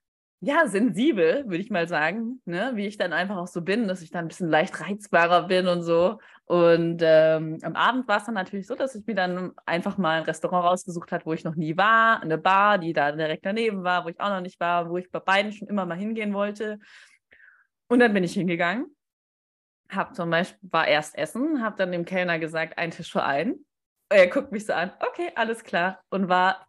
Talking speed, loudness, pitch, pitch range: 225 wpm, -24 LUFS, 185 Hz, 170-215 Hz